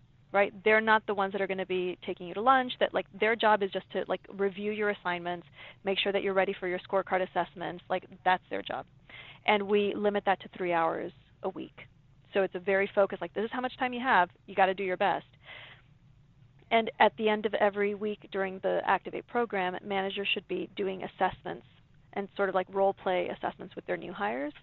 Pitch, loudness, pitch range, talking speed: 195 Hz, -30 LUFS, 180-205 Hz, 225 wpm